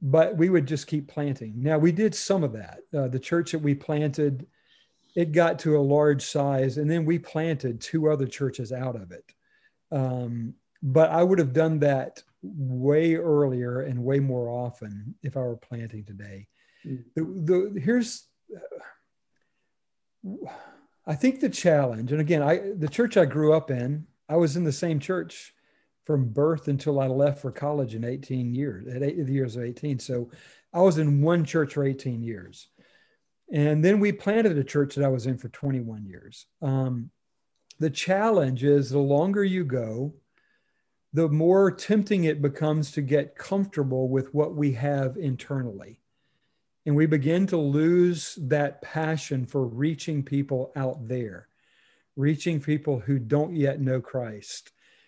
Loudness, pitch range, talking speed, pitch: -25 LUFS, 130-160 Hz, 165 wpm, 145 Hz